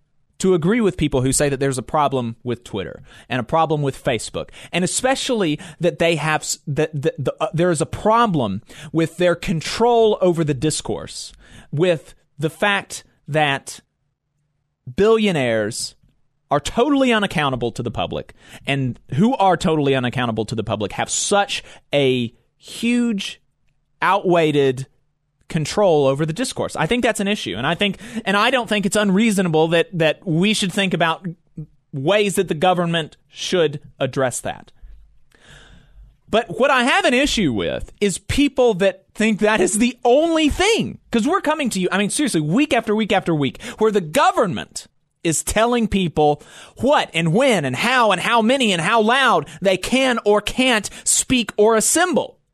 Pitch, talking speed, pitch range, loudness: 170 Hz, 165 wpm, 145-215 Hz, -19 LUFS